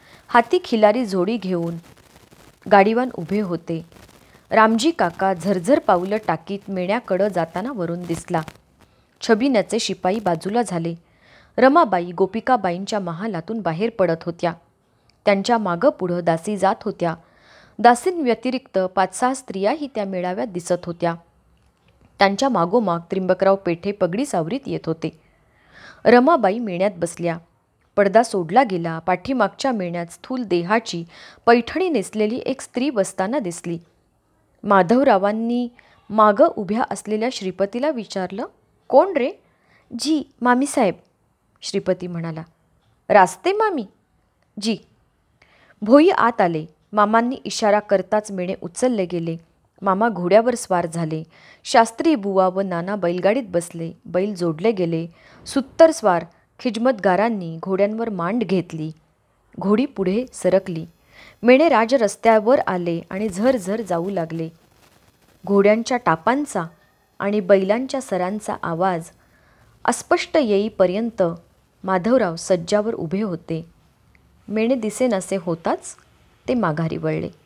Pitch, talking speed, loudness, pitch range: 195 Hz, 110 wpm, -20 LUFS, 170-230 Hz